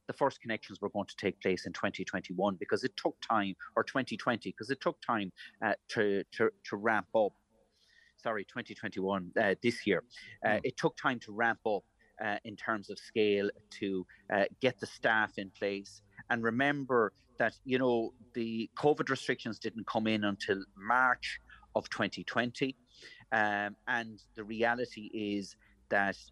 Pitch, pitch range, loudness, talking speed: 110 Hz, 100-120 Hz, -34 LUFS, 160 wpm